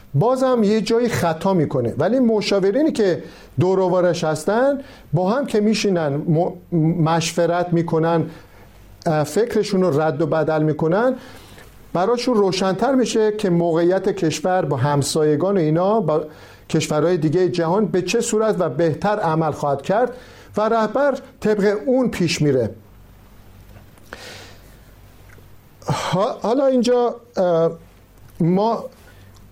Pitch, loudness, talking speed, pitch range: 170 Hz, -19 LUFS, 110 wpm, 145-210 Hz